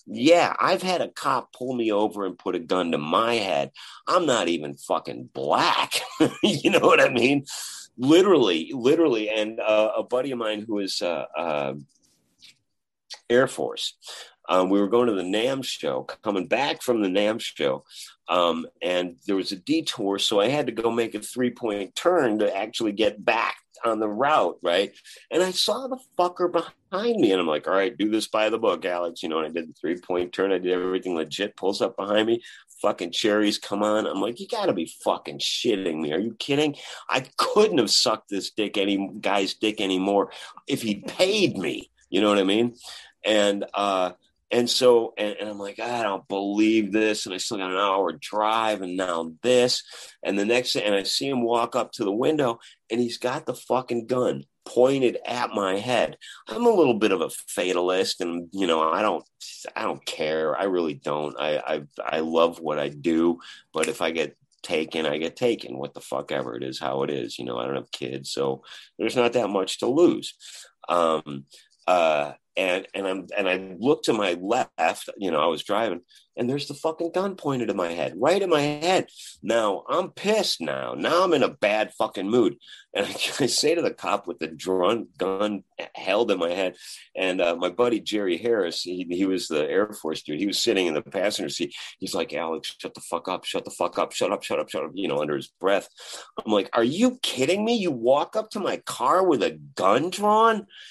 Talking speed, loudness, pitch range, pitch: 215 wpm, -24 LUFS, 90-120 Hz, 105 Hz